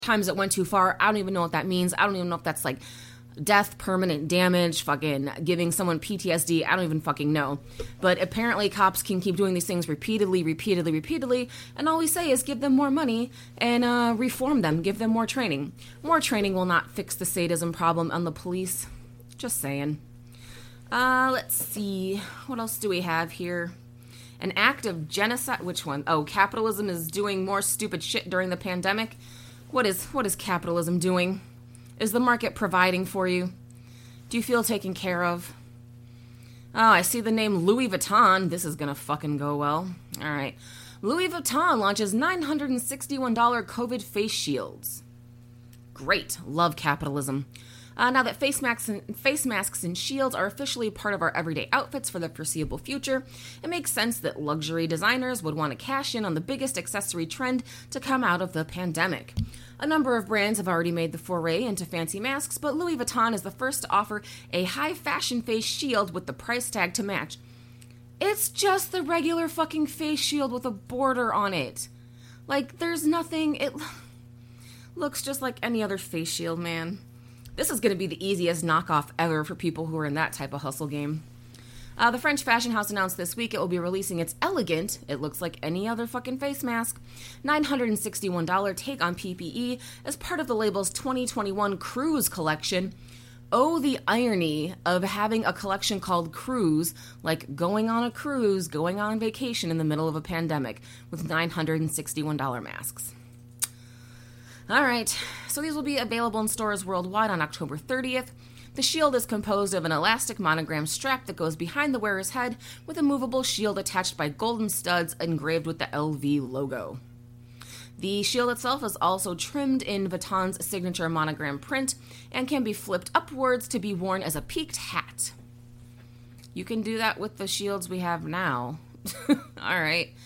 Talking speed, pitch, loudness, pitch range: 180 wpm, 185 Hz, -27 LUFS, 150-230 Hz